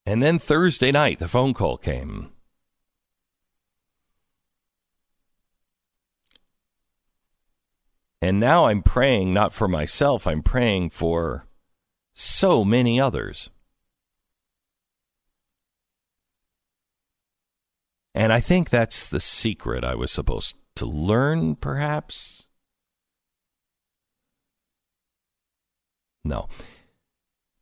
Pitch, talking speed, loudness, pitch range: 110 Hz, 75 wpm, -22 LUFS, 85-130 Hz